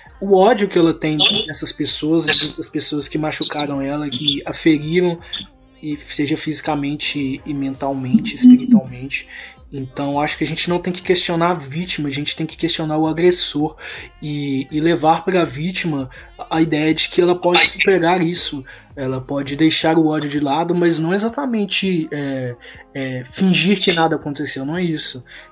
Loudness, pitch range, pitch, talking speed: -17 LUFS, 145-175 Hz, 155 Hz, 170 wpm